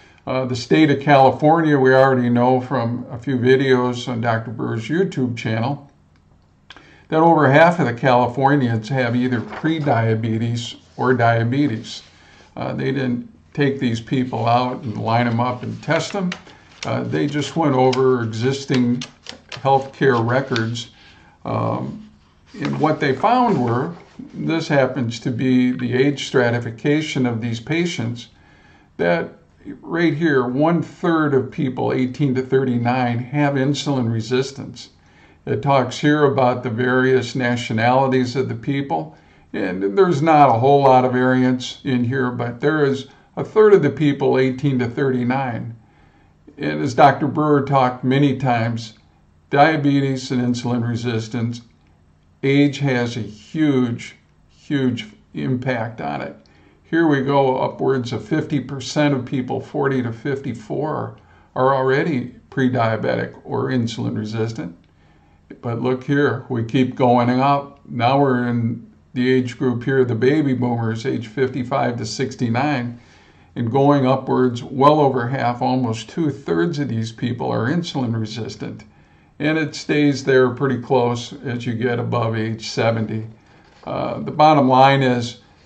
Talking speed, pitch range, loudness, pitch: 140 wpm, 115-140 Hz, -19 LUFS, 125 Hz